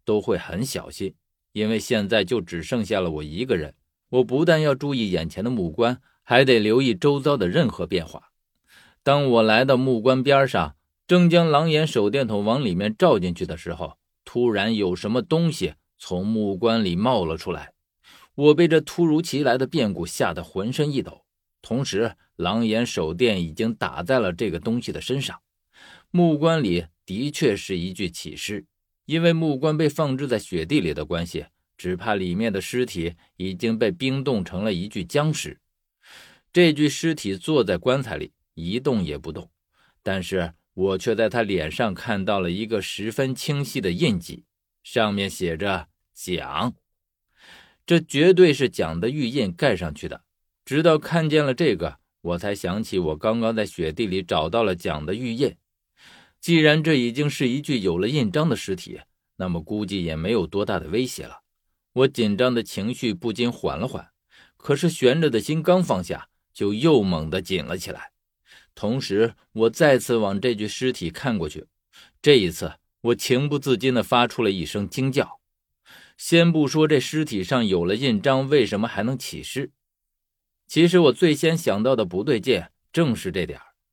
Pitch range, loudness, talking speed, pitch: 95-145 Hz, -22 LUFS, 250 characters per minute, 120 Hz